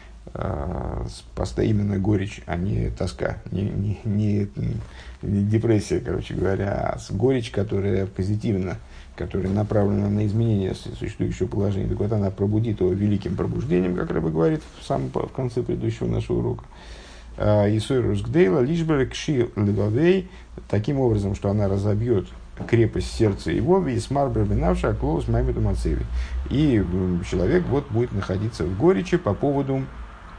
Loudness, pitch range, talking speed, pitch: -23 LUFS, 95-120 Hz, 135 wpm, 105 Hz